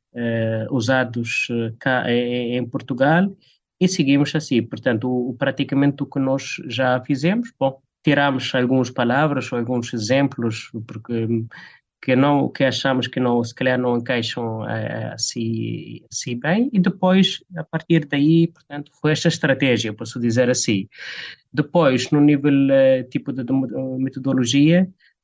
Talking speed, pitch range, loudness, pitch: 140 wpm, 120-145 Hz, -20 LUFS, 130 Hz